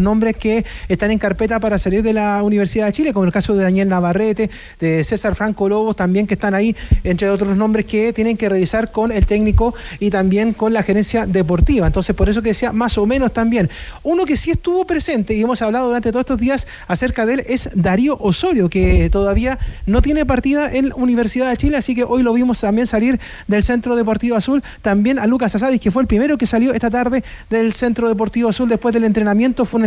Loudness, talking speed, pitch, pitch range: -16 LUFS, 220 wpm, 225 Hz, 205-245 Hz